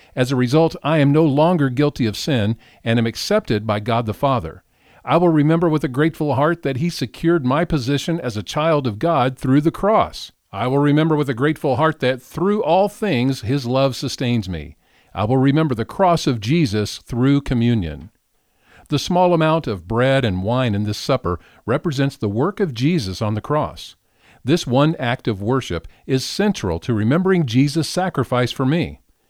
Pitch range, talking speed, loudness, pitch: 115-160 Hz, 190 wpm, -19 LUFS, 135 Hz